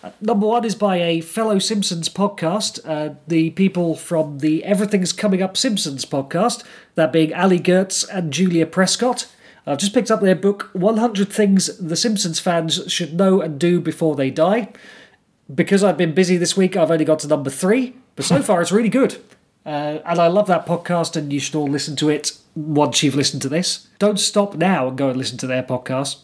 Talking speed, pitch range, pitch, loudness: 205 wpm, 155-205 Hz, 175 Hz, -19 LUFS